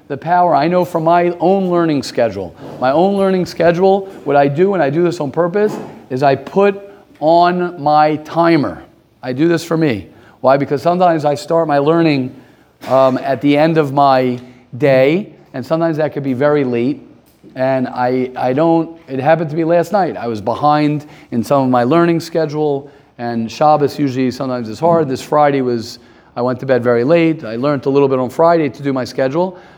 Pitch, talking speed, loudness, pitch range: 150 Hz, 200 wpm, -14 LUFS, 130-165 Hz